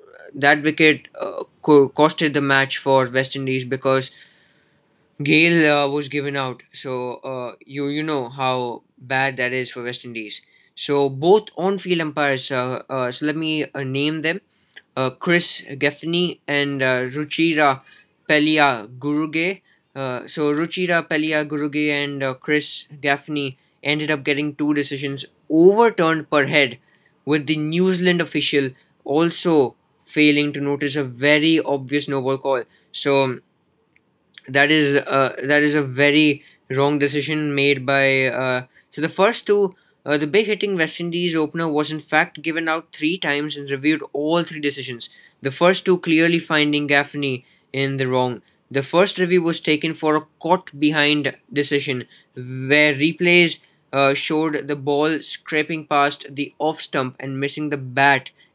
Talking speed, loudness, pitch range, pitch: 155 wpm, -19 LUFS, 135-155 Hz, 145 Hz